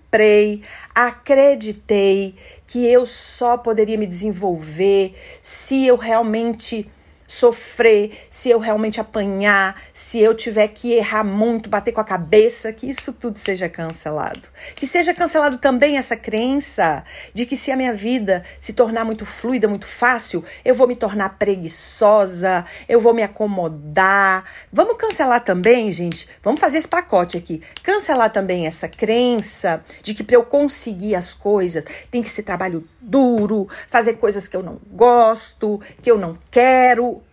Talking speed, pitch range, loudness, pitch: 150 wpm, 195-245 Hz, -17 LUFS, 220 Hz